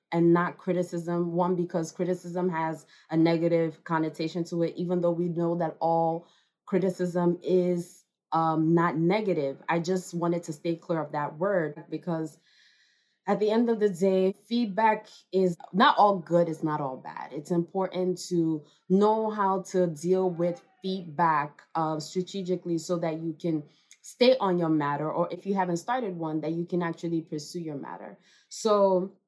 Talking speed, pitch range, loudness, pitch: 165 wpm, 165-185 Hz, -28 LUFS, 175 Hz